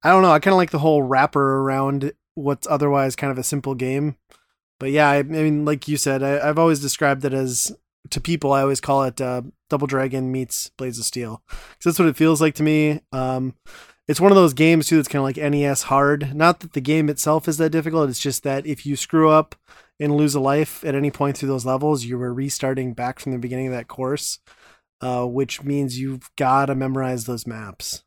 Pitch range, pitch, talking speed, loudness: 130-150 Hz, 140 Hz, 235 wpm, -20 LUFS